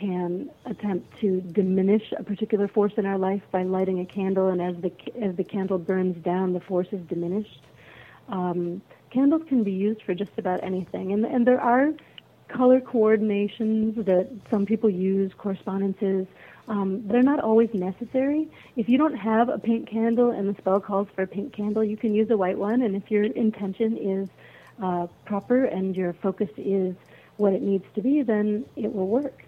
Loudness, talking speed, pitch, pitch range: -25 LUFS, 185 wpm, 205 Hz, 190-225 Hz